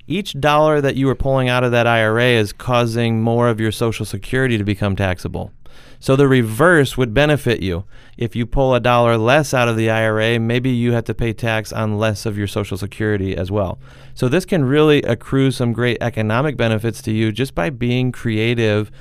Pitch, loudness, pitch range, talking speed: 120 Hz, -17 LUFS, 110-130 Hz, 205 wpm